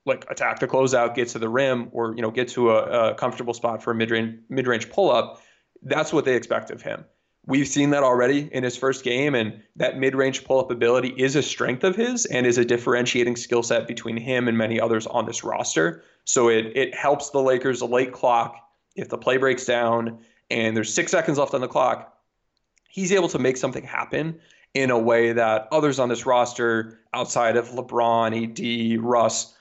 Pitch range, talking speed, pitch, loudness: 115-130 Hz, 205 wpm, 120 Hz, -22 LUFS